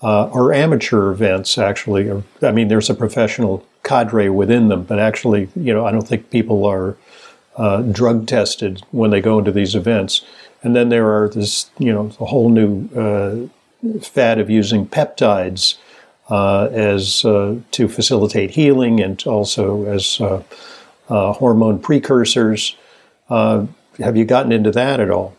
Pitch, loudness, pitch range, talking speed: 110 Hz, -16 LUFS, 100-115 Hz, 160 wpm